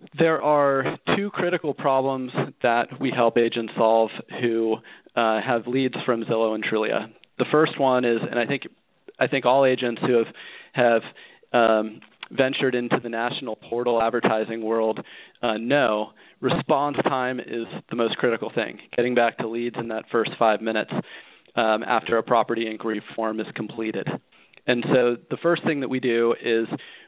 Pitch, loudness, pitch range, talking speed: 120 Hz, -23 LUFS, 115-130 Hz, 165 wpm